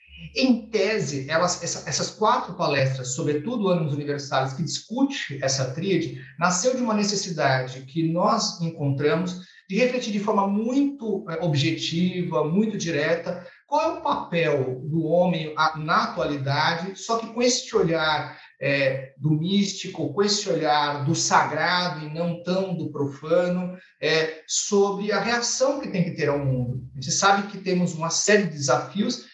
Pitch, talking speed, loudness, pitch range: 170 Hz, 145 wpm, -24 LUFS, 150-200 Hz